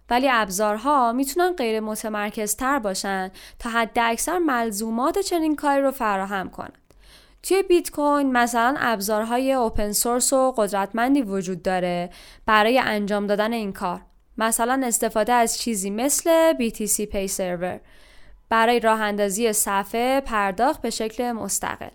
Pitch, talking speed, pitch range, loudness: 230 Hz, 130 wpm, 210-260 Hz, -22 LUFS